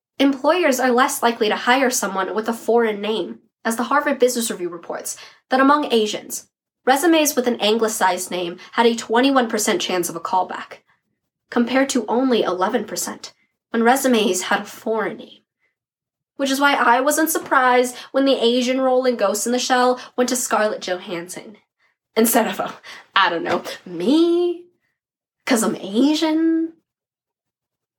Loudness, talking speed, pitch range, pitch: -19 LUFS, 150 wpm, 220-270 Hz, 245 Hz